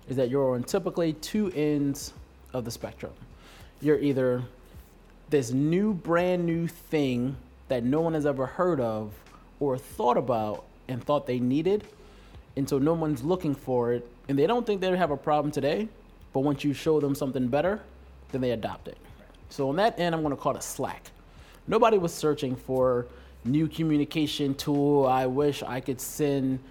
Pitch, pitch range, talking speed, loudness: 145 Hz, 130-160 Hz, 180 wpm, -27 LUFS